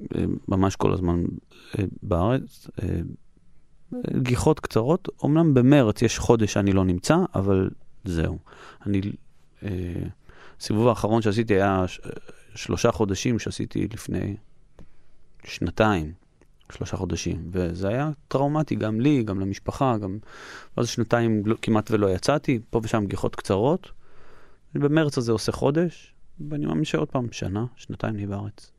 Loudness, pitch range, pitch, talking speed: -24 LUFS, 95-125 Hz, 110 Hz, 120 wpm